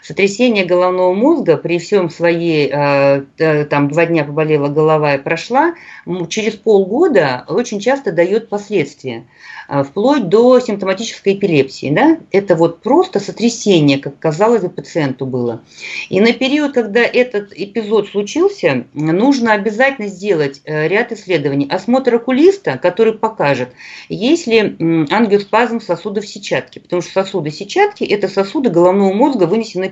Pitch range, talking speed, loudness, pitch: 165-230 Hz, 125 wpm, -14 LUFS, 195 Hz